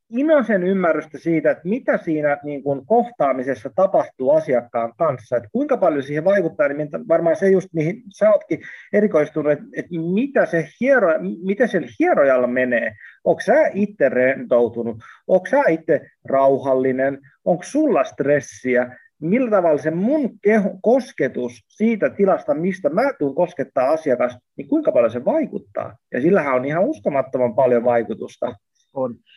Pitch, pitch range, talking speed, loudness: 165 Hz, 135-225 Hz, 140 wpm, -19 LUFS